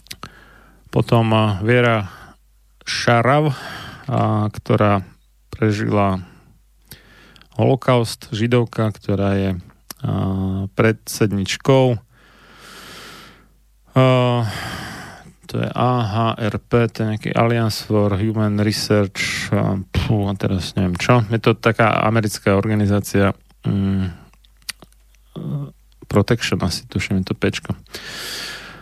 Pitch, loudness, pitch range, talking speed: 110 Hz, -19 LUFS, 100-115 Hz, 75 wpm